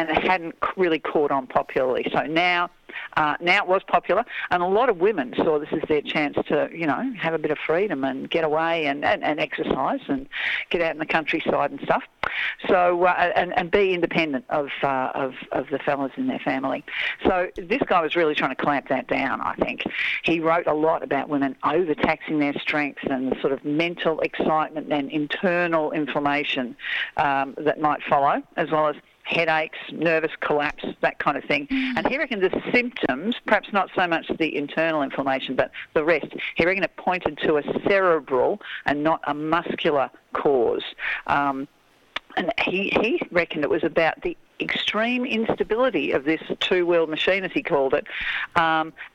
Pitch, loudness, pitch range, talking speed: 165 Hz, -23 LUFS, 150-205 Hz, 185 wpm